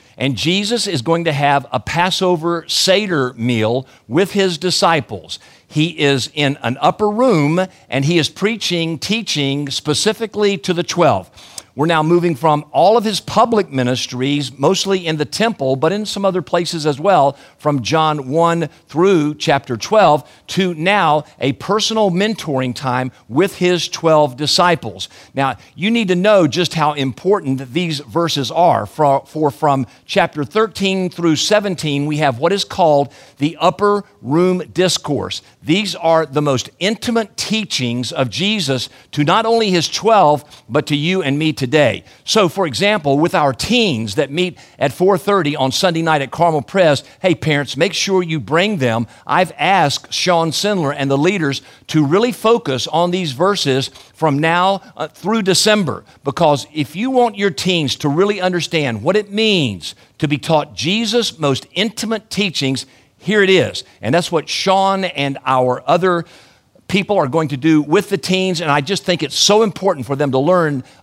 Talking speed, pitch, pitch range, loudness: 170 wpm, 160 Hz, 140-190 Hz, -16 LUFS